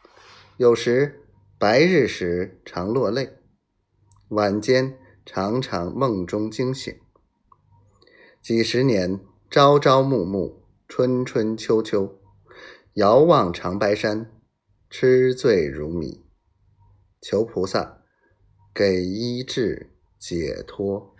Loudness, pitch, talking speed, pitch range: -21 LUFS, 105 Hz, 125 characters per minute, 95-125 Hz